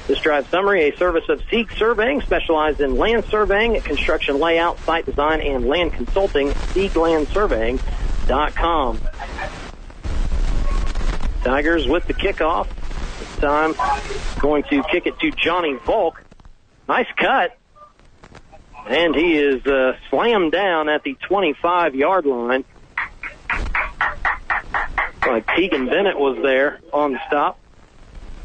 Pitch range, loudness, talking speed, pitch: 130-175 Hz, -19 LUFS, 115 wpm, 145 Hz